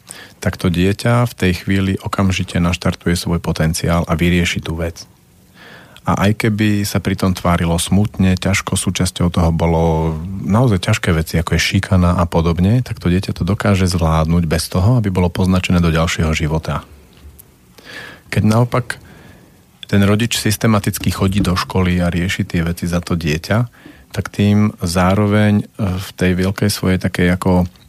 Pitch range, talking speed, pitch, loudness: 85-100 Hz, 150 wpm, 95 Hz, -16 LUFS